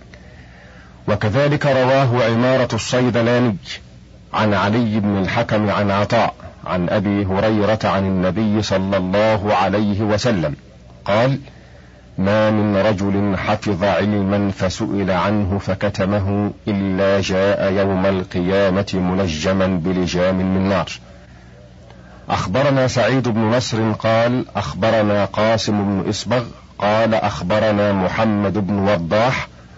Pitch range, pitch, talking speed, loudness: 95-110 Hz, 100 Hz, 100 wpm, -18 LUFS